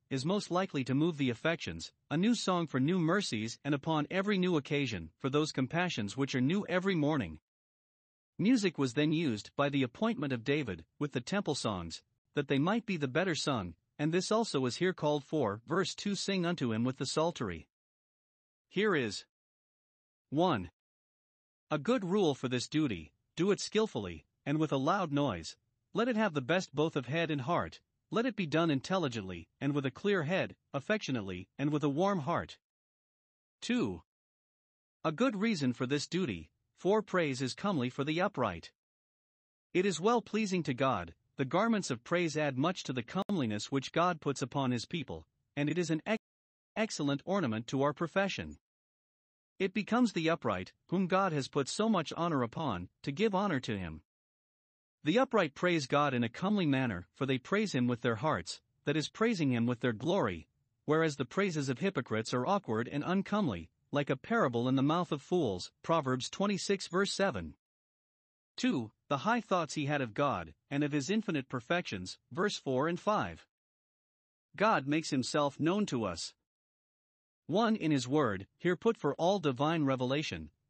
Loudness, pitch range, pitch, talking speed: -33 LUFS, 130-185 Hz, 150 Hz, 180 wpm